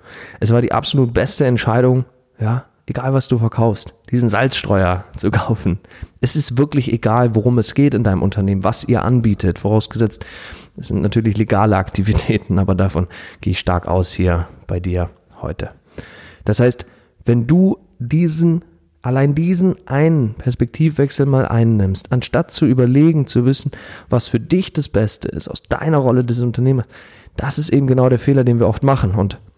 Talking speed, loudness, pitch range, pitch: 165 wpm, -16 LUFS, 100-130 Hz, 120 Hz